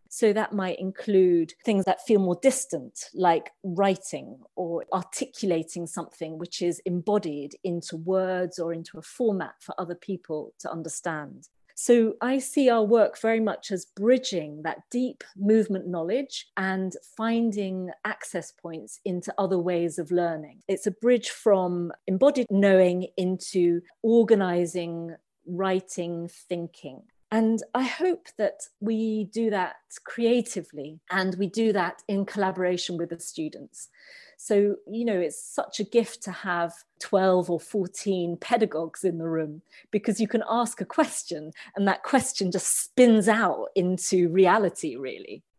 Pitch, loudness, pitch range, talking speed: 190 Hz, -26 LUFS, 175-220 Hz, 140 wpm